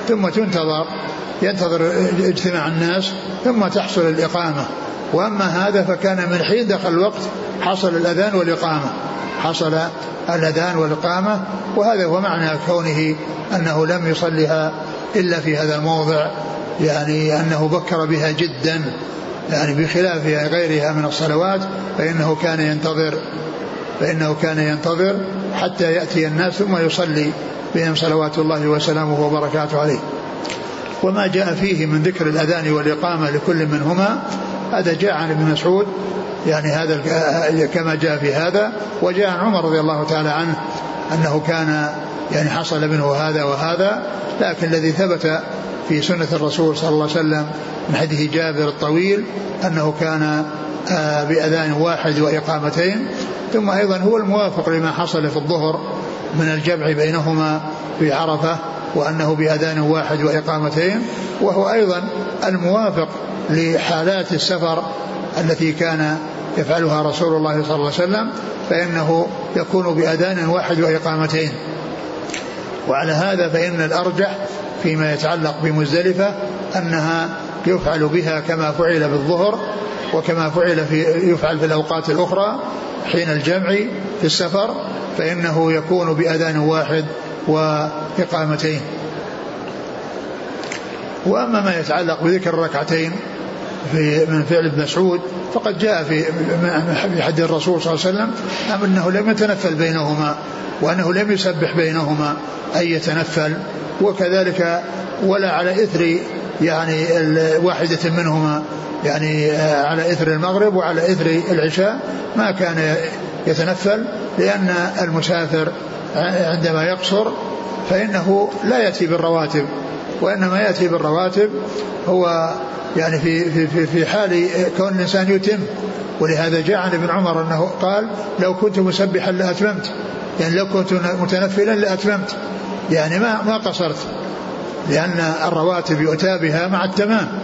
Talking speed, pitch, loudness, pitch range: 115 wpm, 165 Hz, -18 LUFS, 155-185 Hz